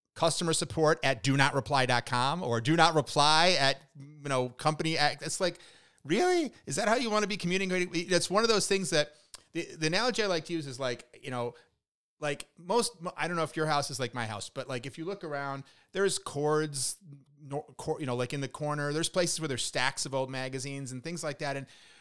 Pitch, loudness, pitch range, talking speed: 150 Hz, -30 LUFS, 135-170 Hz, 225 wpm